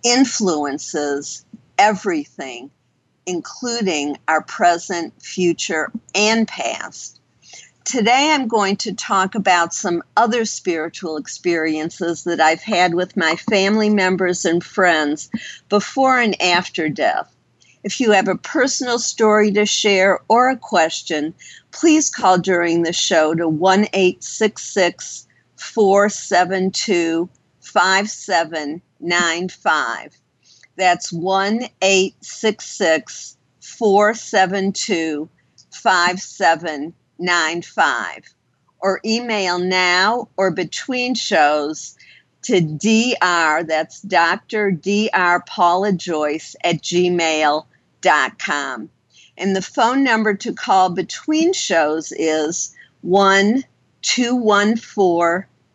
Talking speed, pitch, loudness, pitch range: 100 wpm, 185 Hz, -17 LUFS, 165-215 Hz